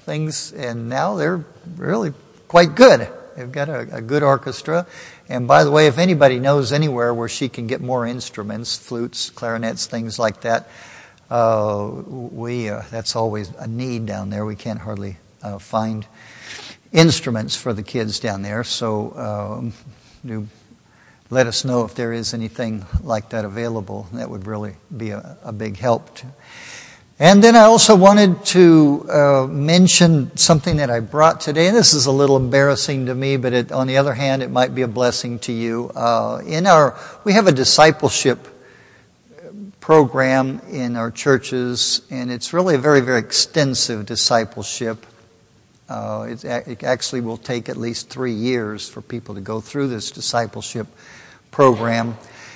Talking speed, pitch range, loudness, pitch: 160 wpm, 115-140 Hz, -17 LUFS, 120 Hz